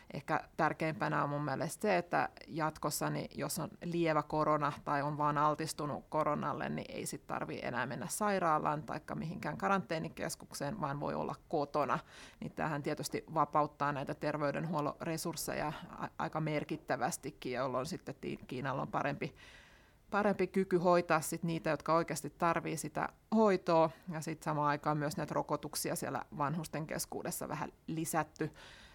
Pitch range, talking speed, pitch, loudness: 150-165 Hz, 140 wpm, 155 Hz, -36 LUFS